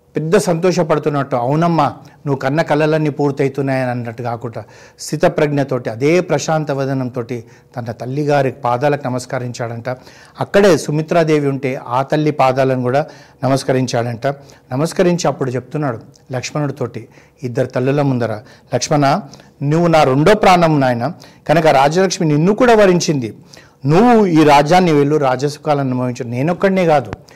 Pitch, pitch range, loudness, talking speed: 145 Hz, 130-155 Hz, -15 LUFS, 110 wpm